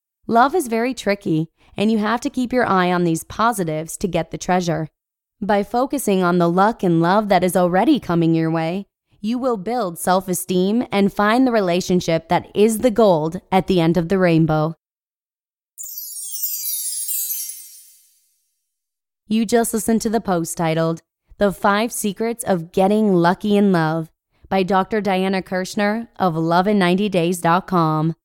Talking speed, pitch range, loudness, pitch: 150 wpm, 165-215 Hz, -19 LUFS, 185 Hz